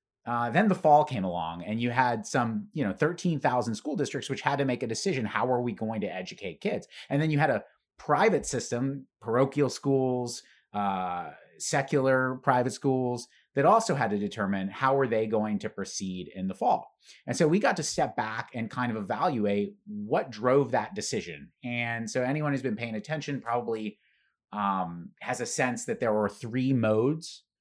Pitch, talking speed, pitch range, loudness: 120 Hz, 190 wpm, 105-135 Hz, -29 LUFS